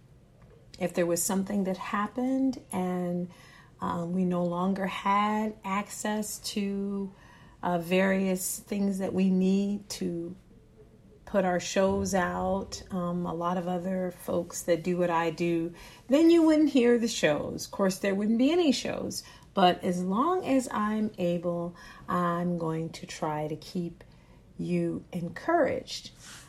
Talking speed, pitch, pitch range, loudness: 145 wpm, 185 Hz, 175-205 Hz, -29 LUFS